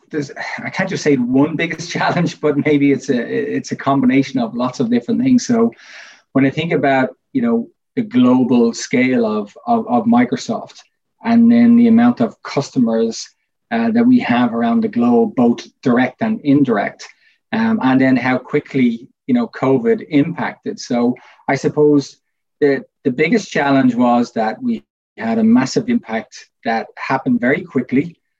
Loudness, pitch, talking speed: -16 LUFS, 205 Hz, 165 wpm